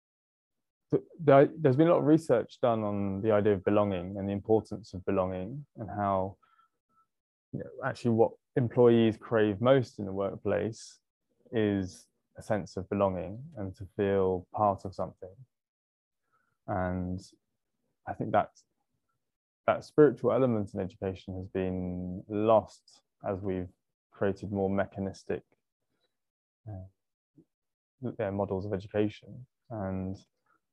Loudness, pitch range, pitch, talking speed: -30 LUFS, 95-115 Hz, 100 Hz, 125 wpm